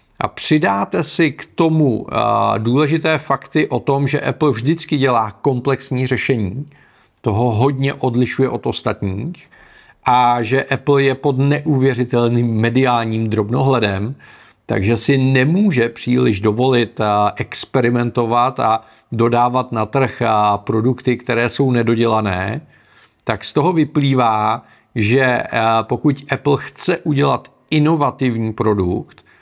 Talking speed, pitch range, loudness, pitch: 110 wpm, 115-140 Hz, -17 LUFS, 125 Hz